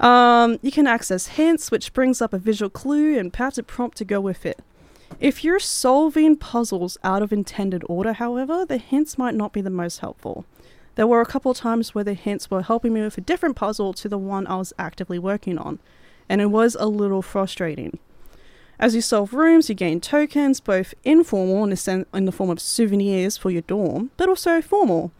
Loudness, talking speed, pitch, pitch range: -21 LUFS, 205 wpm, 220 Hz, 190-260 Hz